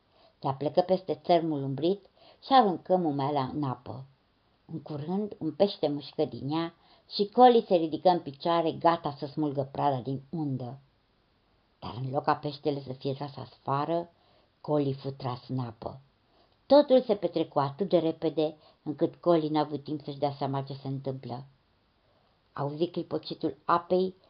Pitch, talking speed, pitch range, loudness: 150 Hz, 155 wpm, 135-170 Hz, -29 LUFS